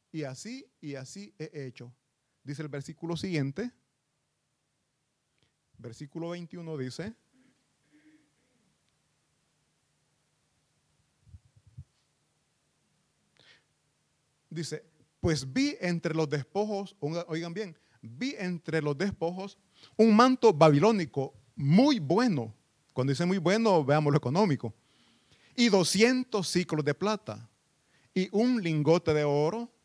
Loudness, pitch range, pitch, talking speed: -28 LUFS, 145-200 Hz, 165 Hz, 95 wpm